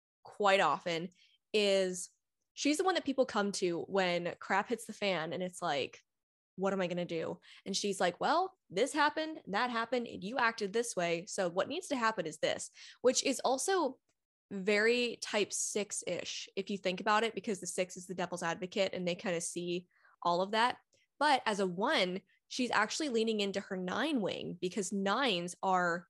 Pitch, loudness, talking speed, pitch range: 200 Hz, -34 LUFS, 195 wpm, 180-235 Hz